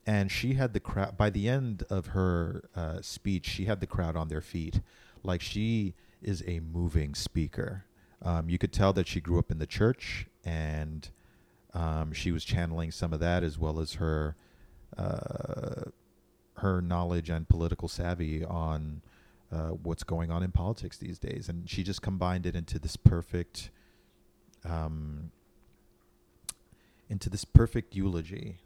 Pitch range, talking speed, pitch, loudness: 80-100 Hz, 160 wpm, 90 Hz, -32 LUFS